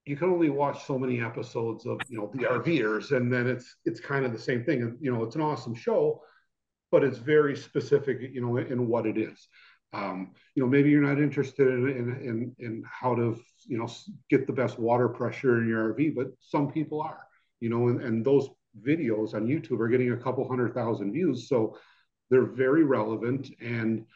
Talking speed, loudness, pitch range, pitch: 205 wpm, -28 LUFS, 115-140 Hz, 125 Hz